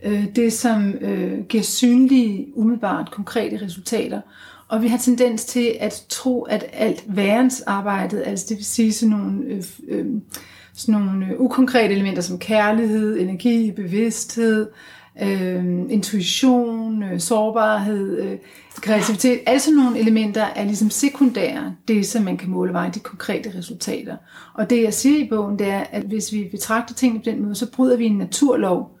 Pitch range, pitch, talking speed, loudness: 205-235 Hz, 220 Hz, 165 wpm, -20 LUFS